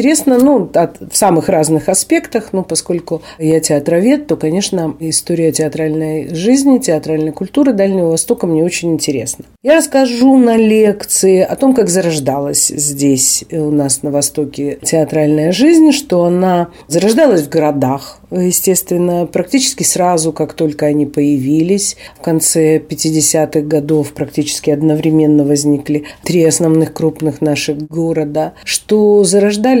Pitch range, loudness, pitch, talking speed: 155-195 Hz, -12 LUFS, 160 Hz, 130 wpm